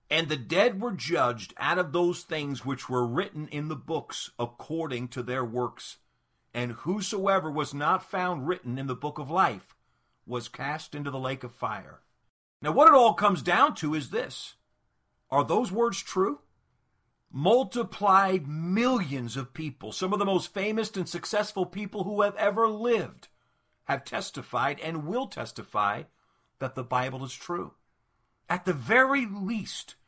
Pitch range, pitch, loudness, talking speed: 135-200 Hz, 165 Hz, -28 LUFS, 160 wpm